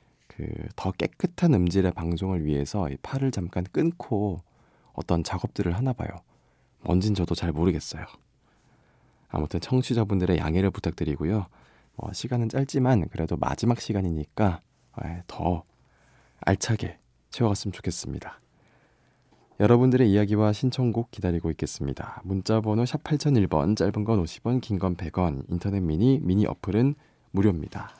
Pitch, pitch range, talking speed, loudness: 95 Hz, 85-115 Hz, 300 characters per minute, -26 LUFS